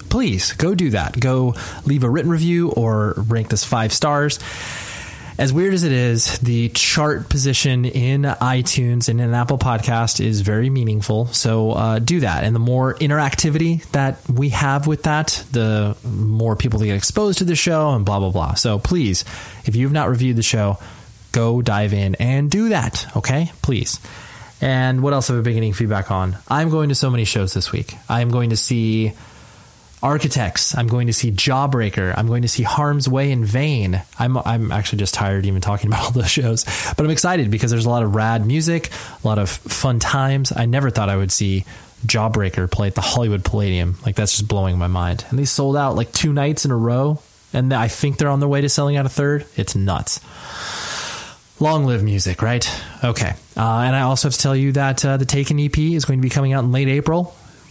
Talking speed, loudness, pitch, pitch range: 215 wpm, -18 LUFS, 120 Hz, 110-140 Hz